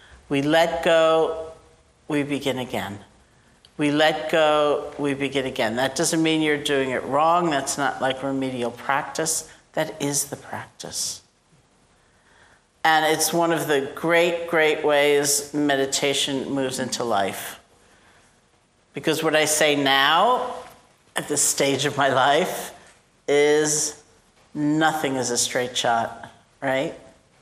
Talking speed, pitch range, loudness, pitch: 125 wpm, 135-155 Hz, -22 LUFS, 145 Hz